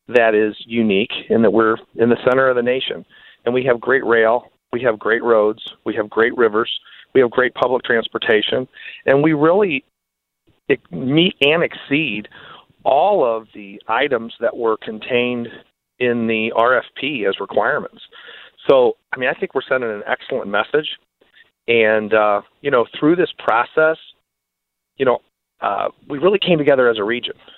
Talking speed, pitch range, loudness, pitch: 165 wpm, 110-150 Hz, -17 LUFS, 120 Hz